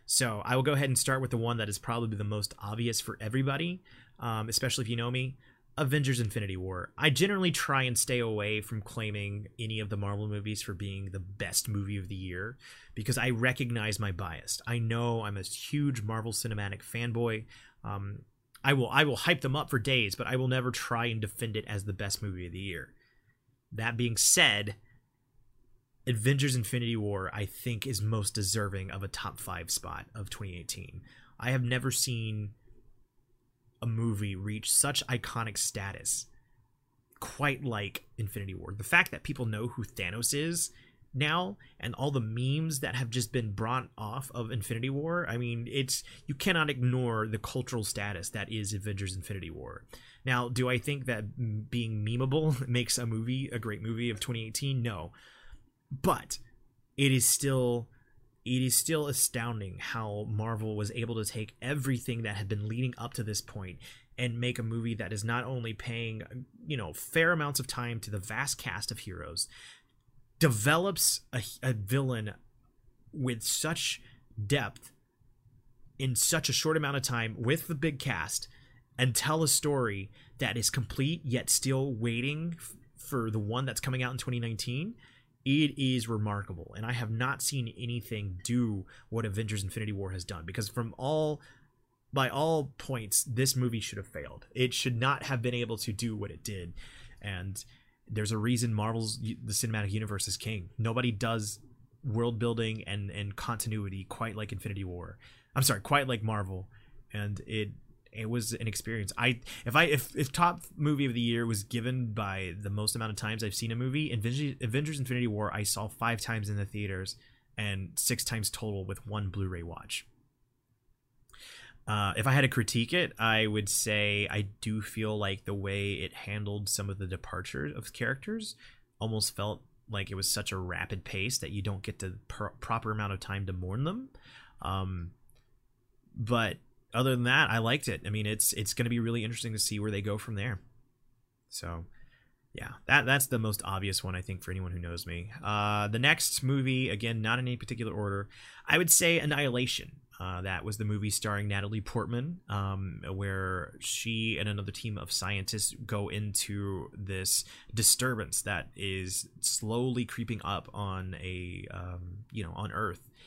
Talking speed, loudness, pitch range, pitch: 180 wpm, -31 LUFS, 105-125 Hz, 115 Hz